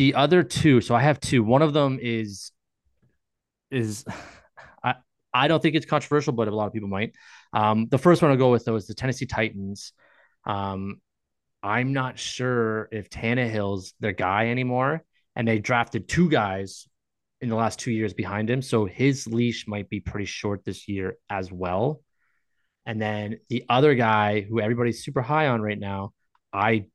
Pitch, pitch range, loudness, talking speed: 115 Hz, 105-130 Hz, -24 LUFS, 185 wpm